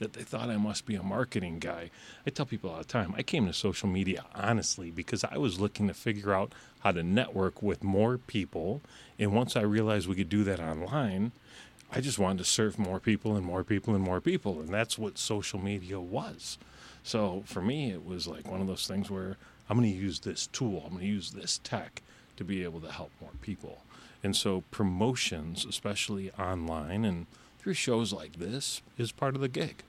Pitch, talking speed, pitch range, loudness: 100 Hz, 215 wpm, 95-110 Hz, -32 LUFS